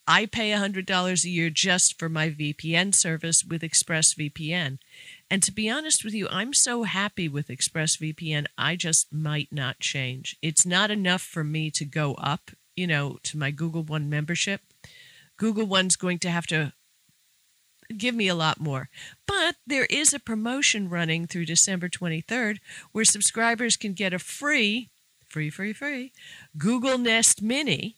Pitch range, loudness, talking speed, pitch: 155-215 Hz, -24 LUFS, 160 wpm, 180 Hz